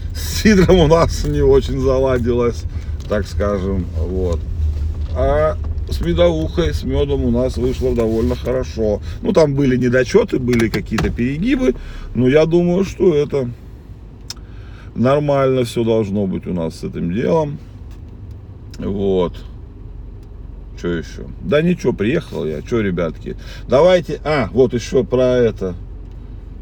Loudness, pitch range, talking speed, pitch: -17 LUFS, 90-130 Hz, 125 wpm, 110 Hz